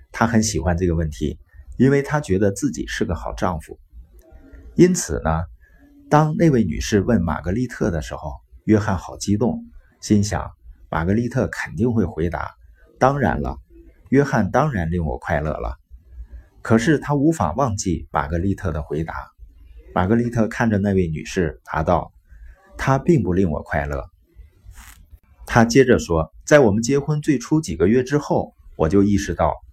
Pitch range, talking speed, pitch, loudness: 75-115 Hz, 240 characters per minute, 90 Hz, -20 LUFS